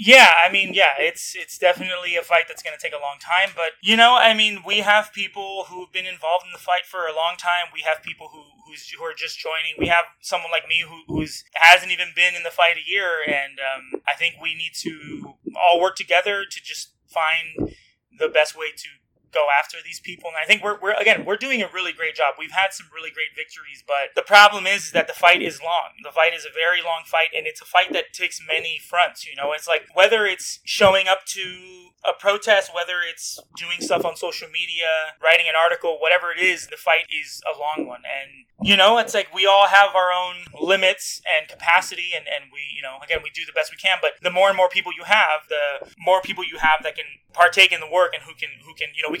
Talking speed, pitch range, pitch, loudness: 250 wpm, 160-195 Hz, 180 Hz, -19 LUFS